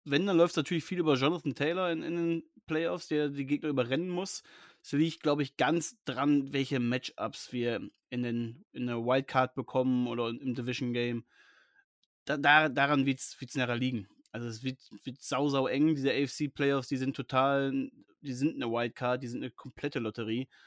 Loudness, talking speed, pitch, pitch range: -31 LUFS, 185 wpm, 135 Hz, 125-150 Hz